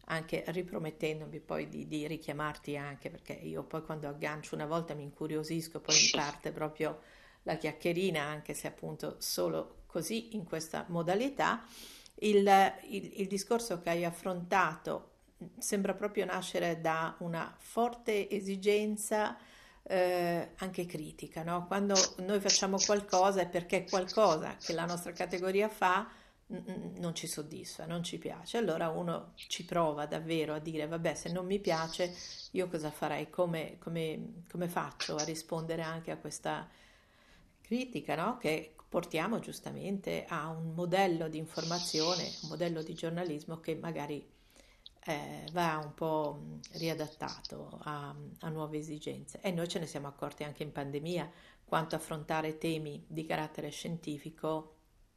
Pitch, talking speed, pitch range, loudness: 165 Hz, 140 wpm, 155-185 Hz, -35 LUFS